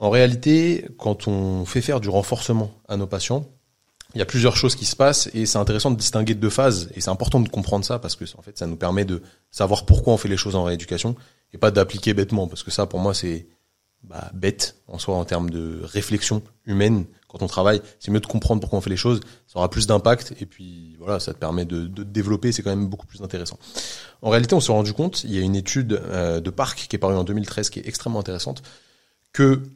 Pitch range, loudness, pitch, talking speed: 95-115 Hz, -22 LUFS, 105 Hz, 250 wpm